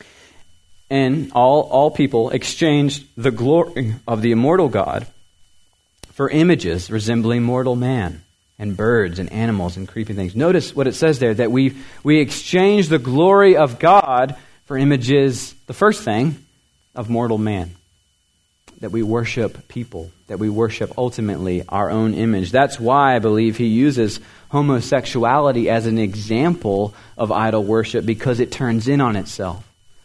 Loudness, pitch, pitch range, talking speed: -18 LUFS, 115 Hz, 105-135 Hz, 150 wpm